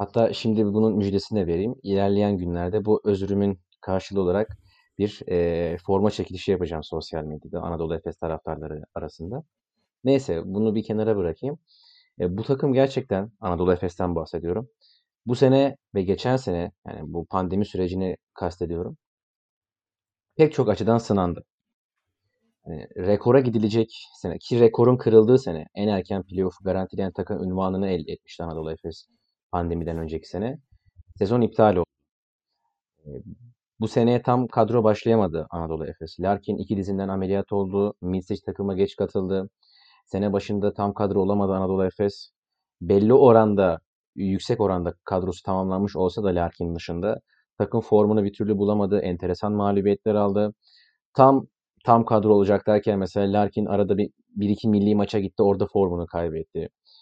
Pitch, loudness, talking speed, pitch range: 100 Hz, -23 LUFS, 140 wpm, 90-110 Hz